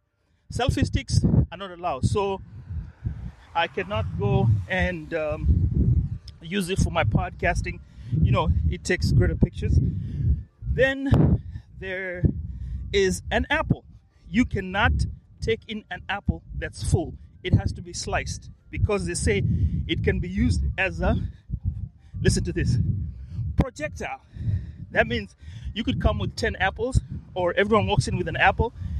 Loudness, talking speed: -25 LUFS, 140 wpm